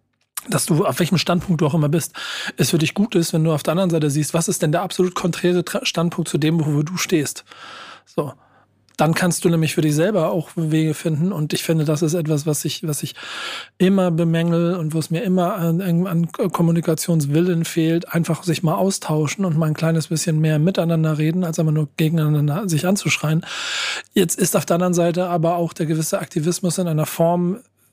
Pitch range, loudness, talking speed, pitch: 160-180 Hz, -20 LUFS, 210 wpm, 170 Hz